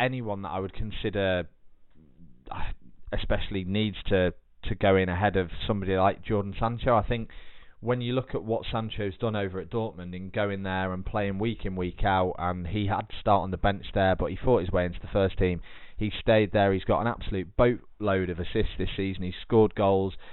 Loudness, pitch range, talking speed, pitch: -28 LUFS, 95-110 Hz, 210 wpm, 100 Hz